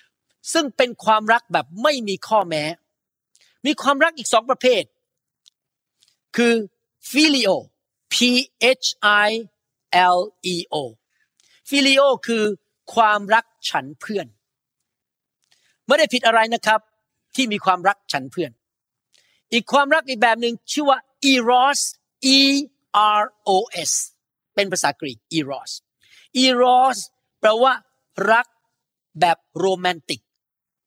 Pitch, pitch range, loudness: 225 Hz, 190-260 Hz, -19 LUFS